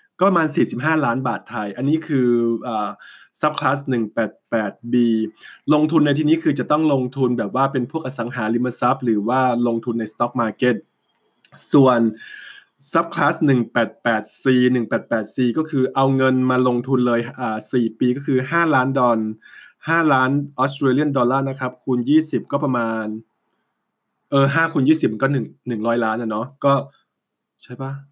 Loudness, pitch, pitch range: -20 LUFS, 130 Hz, 120-140 Hz